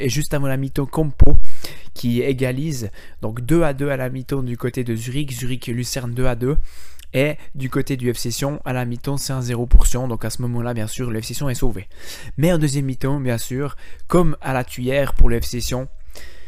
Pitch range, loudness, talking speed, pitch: 120-140 Hz, -22 LUFS, 210 wpm, 130 Hz